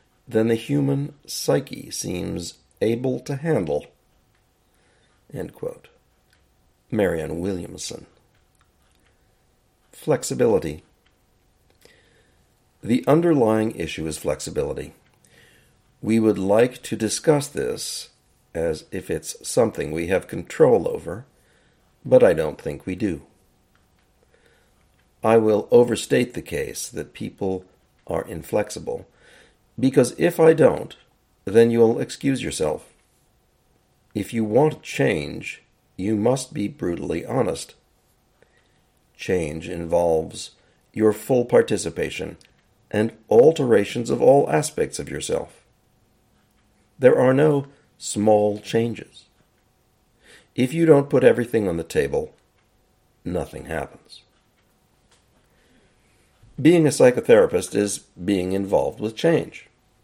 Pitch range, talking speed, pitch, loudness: 105-160 Hz, 95 wpm, 120 Hz, -21 LUFS